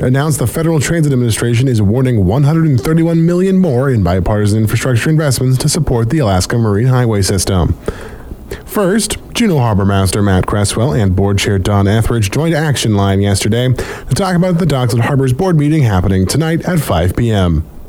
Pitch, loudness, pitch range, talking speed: 120 Hz, -13 LUFS, 100-150 Hz, 180 wpm